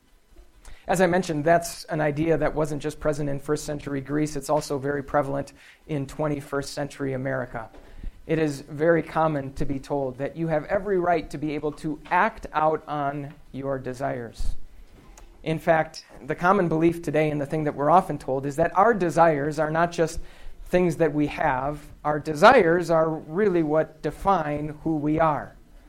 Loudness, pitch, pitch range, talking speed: -24 LUFS, 150 Hz, 140-160 Hz, 175 wpm